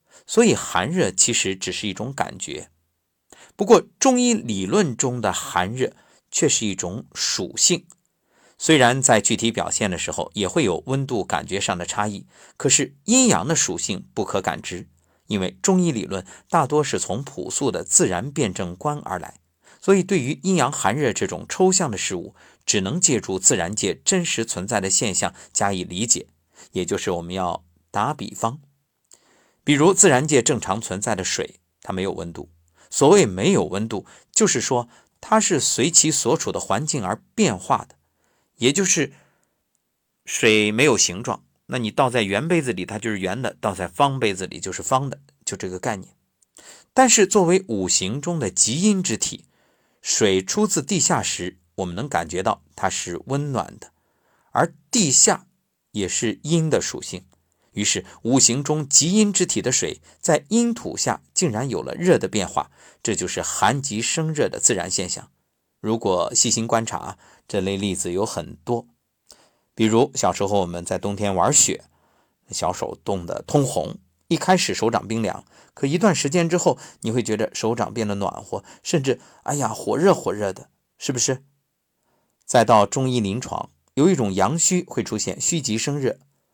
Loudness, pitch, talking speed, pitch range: -21 LUFS, 120 Hz, 245 characters per minute, 100-160 Hz